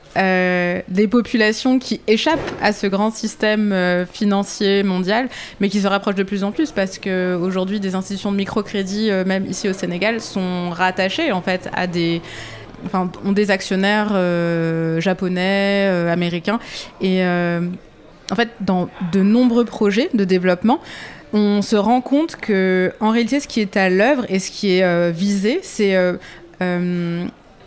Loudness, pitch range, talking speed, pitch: -18 LUFS, 180-215 Hz, 165 wpm, 195 Hz